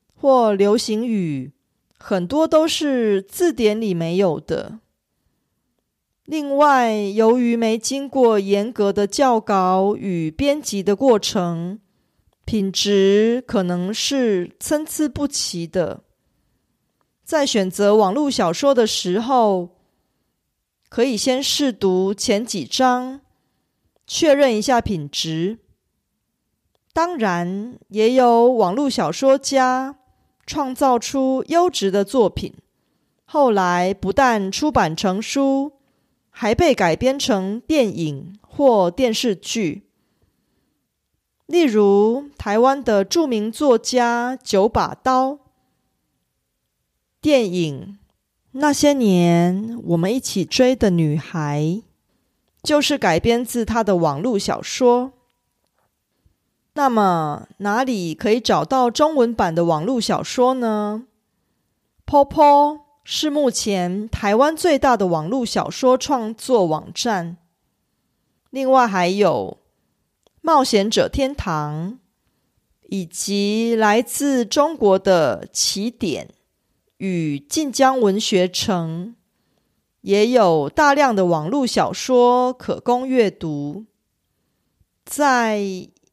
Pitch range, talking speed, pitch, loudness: 195-265 Hz, 150 characters per minute, 225 Hz, -18 LUFS